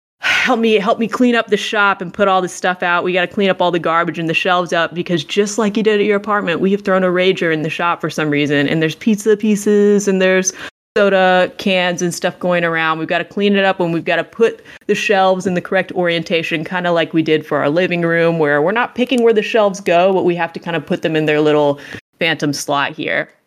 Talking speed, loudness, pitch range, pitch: 270 wpm, -15 LUFS, 165-205 Hz, 180 Hz